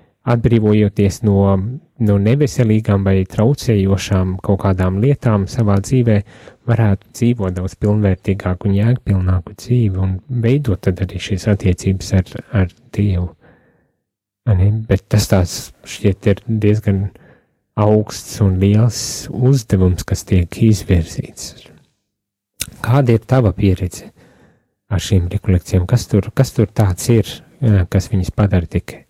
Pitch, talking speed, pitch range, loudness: 100 Hz, 105 wpm, 95-115 Hz, -16 LUFS